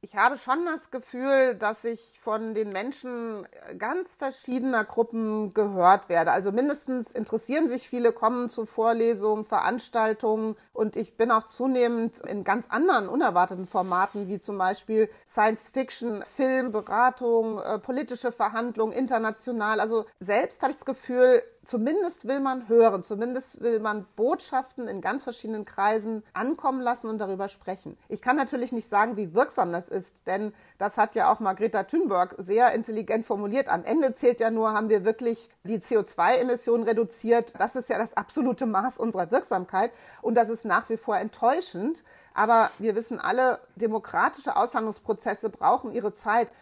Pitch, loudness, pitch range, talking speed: 230 Hz, -26 LUFS, 215-255 Hz, 155 wpm